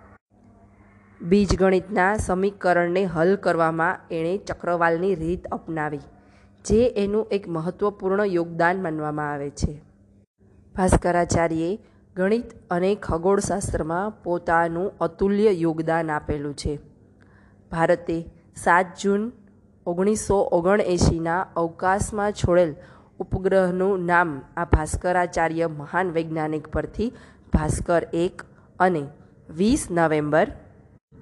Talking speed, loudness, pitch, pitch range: 85 wpm, -23 LUFS, 175 Hz, 160-190 Hz